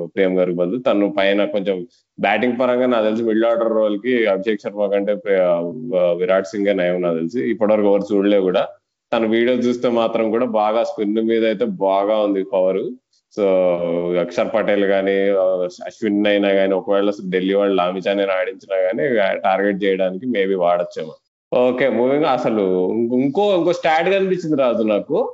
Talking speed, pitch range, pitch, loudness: 150 wpm, 95-115 Hz, 100 Hz, -18 LUFS